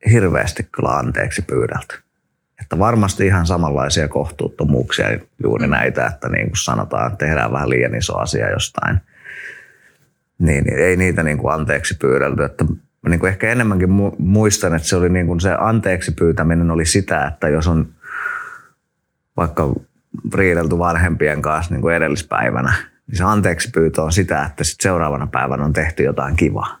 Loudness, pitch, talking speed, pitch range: -17 LUFS, 85 Hz, 150 wpm, 80-95 Hz